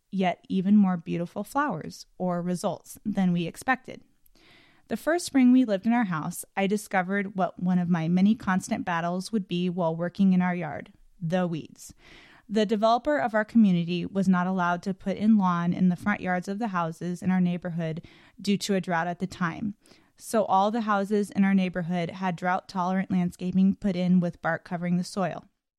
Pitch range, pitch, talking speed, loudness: 175-210 Hz, 185 Hz, 195 wpm, -26 LUFS